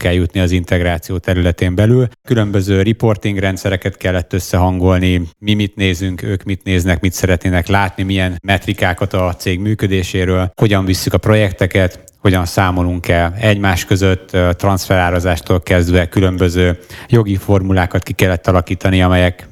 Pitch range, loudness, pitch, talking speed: 90-100 Hz, -14 LUFS, 95 Hz, 130 wpm